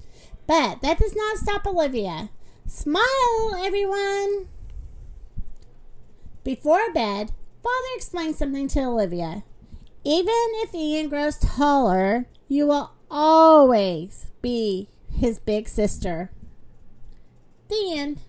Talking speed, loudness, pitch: 95 wpm, -22 LUFS, 295 Hz